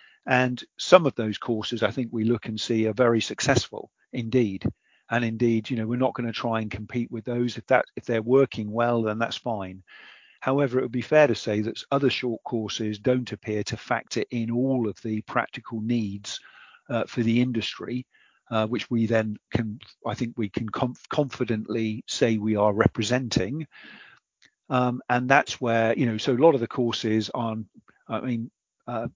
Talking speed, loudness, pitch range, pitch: 190 wpm, -26 LUFS, 110-125 Hz, 115 Hz